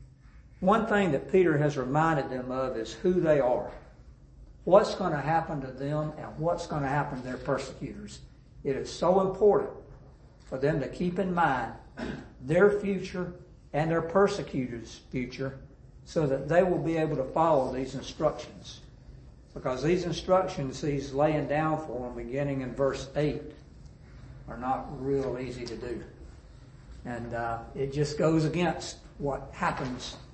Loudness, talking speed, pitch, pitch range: -29 LUFS, 155 wpm, 145 Hz, 130-165 Hz